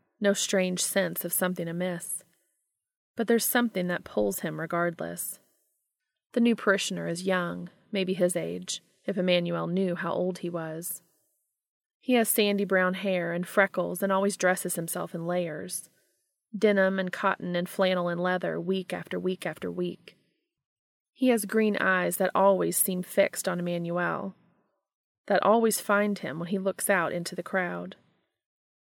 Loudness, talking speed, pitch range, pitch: -28 LUFS, 155 wpm, 175-200 Hz, 185 Hz